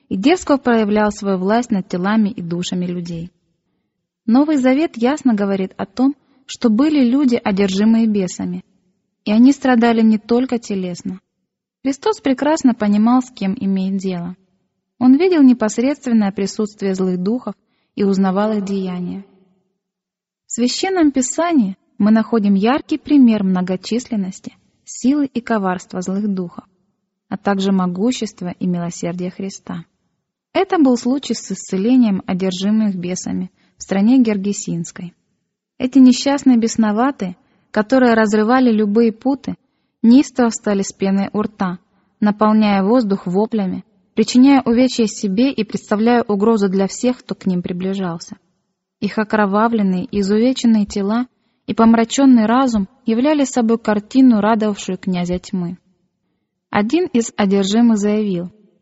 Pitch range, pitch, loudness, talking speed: 195-245 Hz, 210 Hz, -16 LUFS, 120 wpm